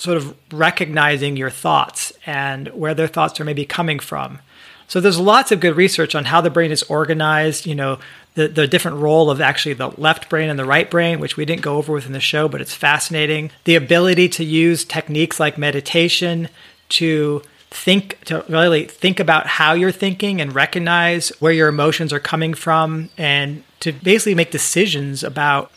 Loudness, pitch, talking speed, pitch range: -16 LUFS, 160 Hz, 190 wpm, 150-170 Hz